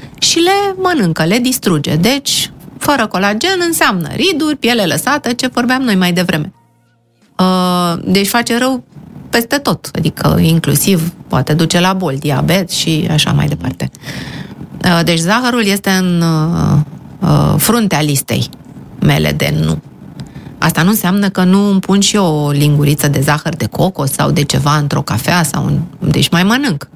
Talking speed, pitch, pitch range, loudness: 160 wpm, 175 Hz, 150-205 Hz, -12 LUFS